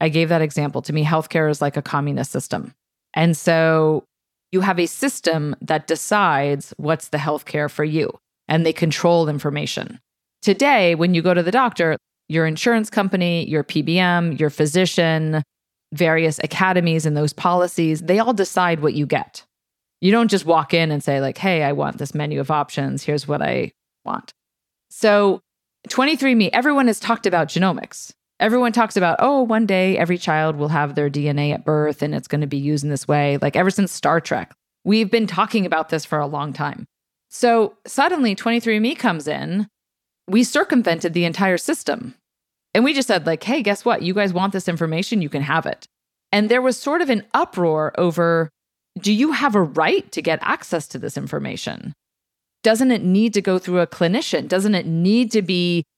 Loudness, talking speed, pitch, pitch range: -19 LUFS, 190 wpm, 170 Hz, 155-205 Hz